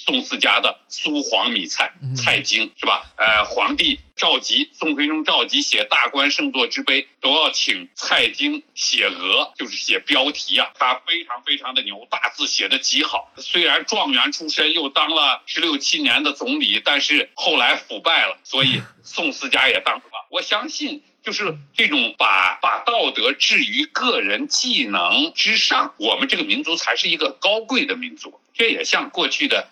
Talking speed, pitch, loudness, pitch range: 255 characters per minute, 280 Hz, -18 LUFS, 215-295 Hz